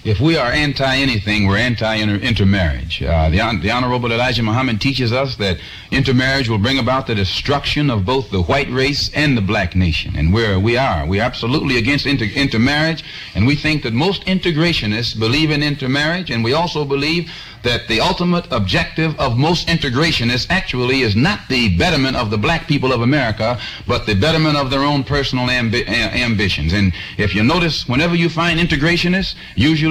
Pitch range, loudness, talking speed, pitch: 110-150 Hz, -16 LUFS, 185 wpm, 130 Hz